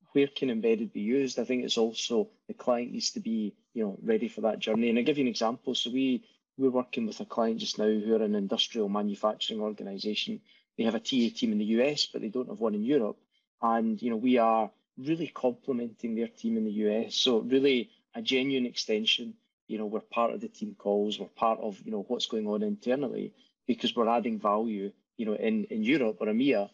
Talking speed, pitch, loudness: 225 wpm, 125 Hz, -30 LUFS